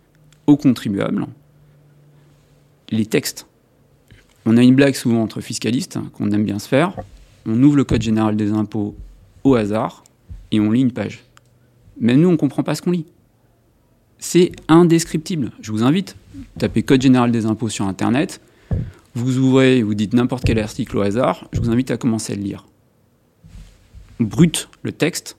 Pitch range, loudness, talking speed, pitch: 105-140 Hz, -18 LUFS, 165 wpm, 120 Hz